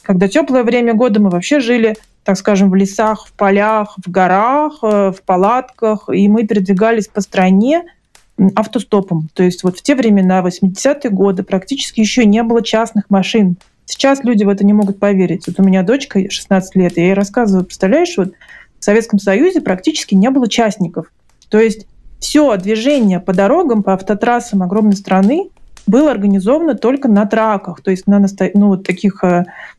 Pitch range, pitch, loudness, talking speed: 190-235 Hz, 205 Hz, -13 LUFS, 165 wpm